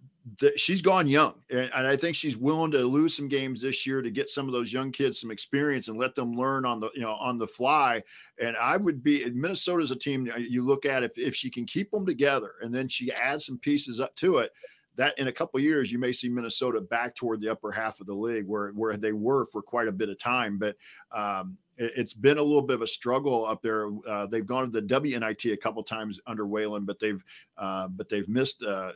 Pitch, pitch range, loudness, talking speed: 125 Hz, 110-140 Hz, -28 LUFS, 245 wpm